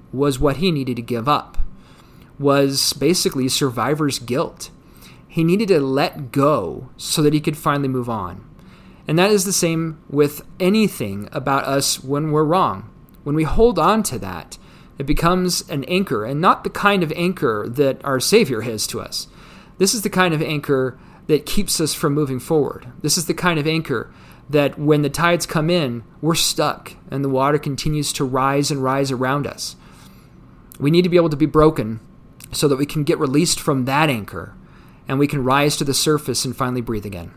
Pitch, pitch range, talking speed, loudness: 150 Hz, 135-165 Hz, 195 wpm, -19 LUFS